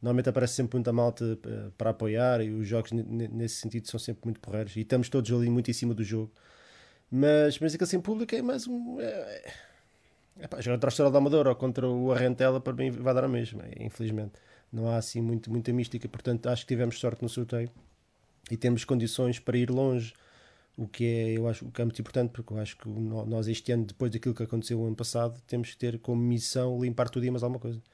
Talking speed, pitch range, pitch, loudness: 225 wpm, 115-125 Hz, 120 Hz, -30 LUFS